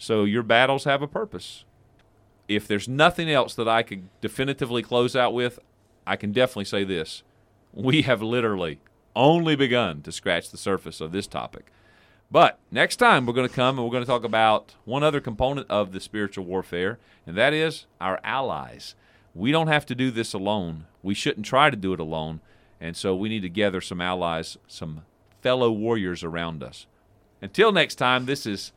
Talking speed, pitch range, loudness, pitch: 190 wpm, 95-125 Hz, -24 LUFS, 110 Hz